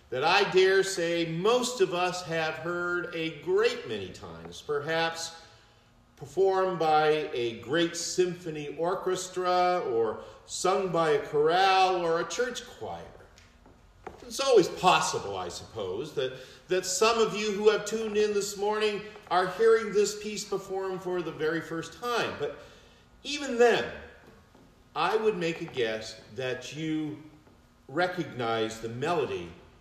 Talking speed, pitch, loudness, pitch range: 135 wpm, 180 Hz, -28 LUFS, 160-210 Hz